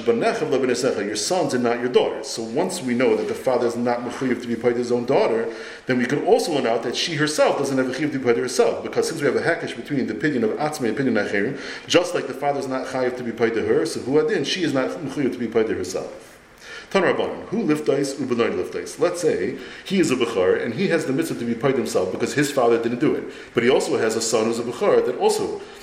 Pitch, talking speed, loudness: 165 Hz, 260 wpm, -22 LUFS